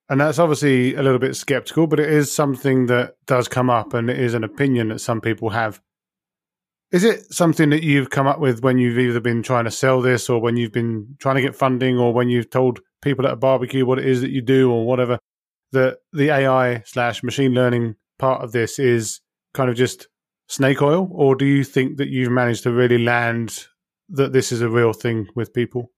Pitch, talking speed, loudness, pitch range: 130 Hz, 225 wpm, -19 LUFS, 120-140 Hz